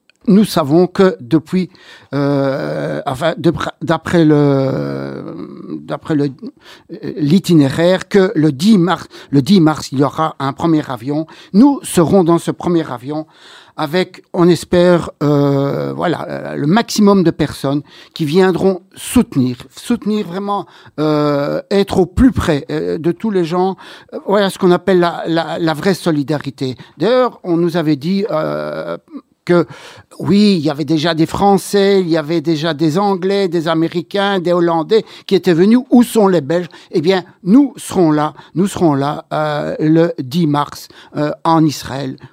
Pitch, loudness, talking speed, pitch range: 165 Hz, -15 LUFS, 155 wpm, 150-190 Hz